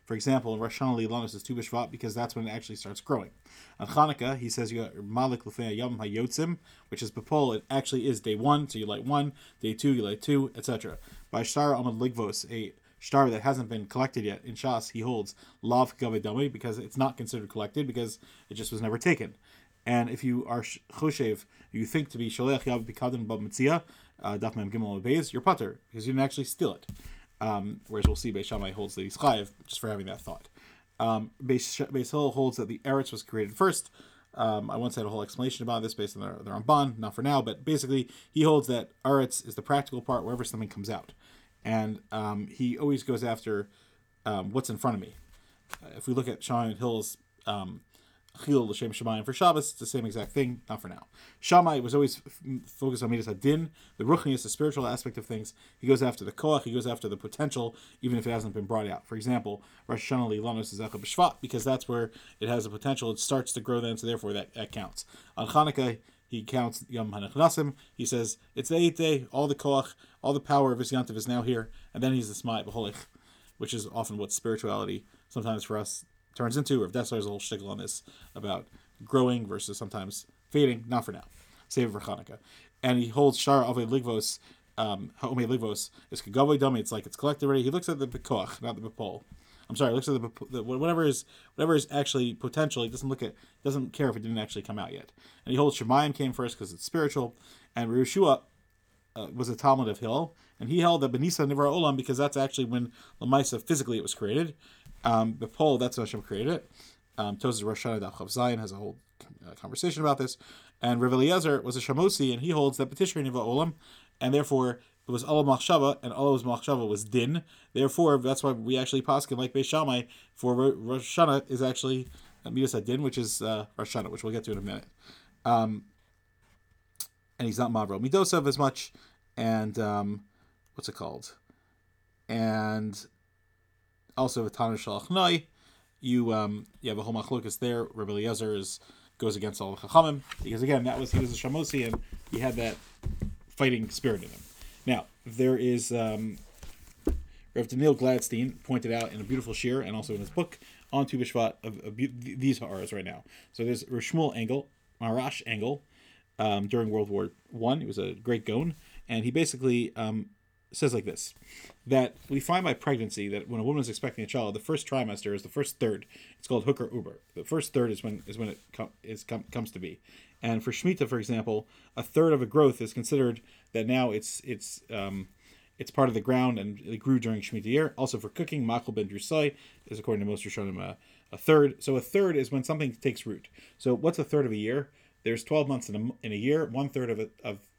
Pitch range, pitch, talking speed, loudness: 110-135 Hz, 120 Hz, 205 wpm, -30 LUFS